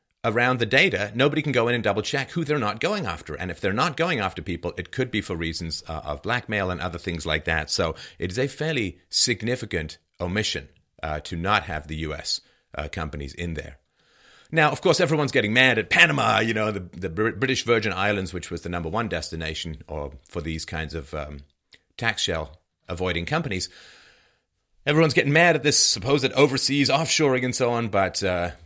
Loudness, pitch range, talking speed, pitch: -23 LUFS, 80-125 Hz, 200 wpm, 95 Hz